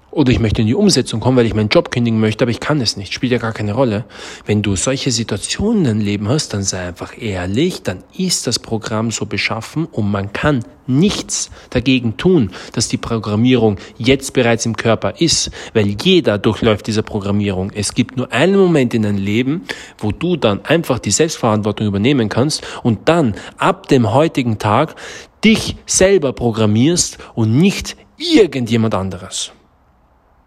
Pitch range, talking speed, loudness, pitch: 105-135 Hz, 175 wpm, -16 LUFS, 115 Hz